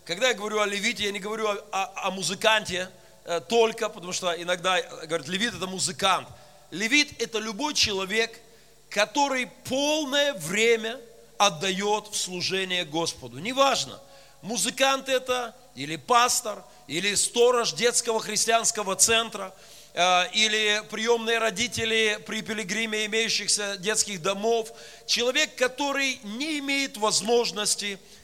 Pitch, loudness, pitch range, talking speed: 215 Hz, -25 LUFS, 190-235 Hz, 115 wpm